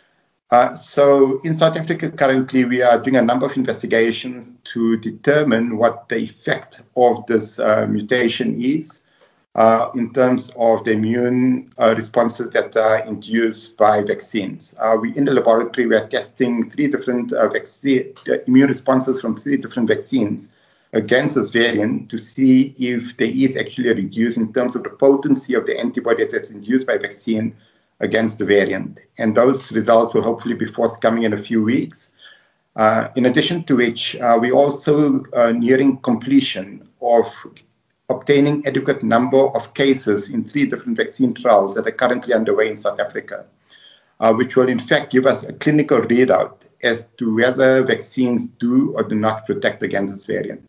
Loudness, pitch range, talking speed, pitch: -18 LUFS, 115-135 Hz, 170 wpm, 125 Hz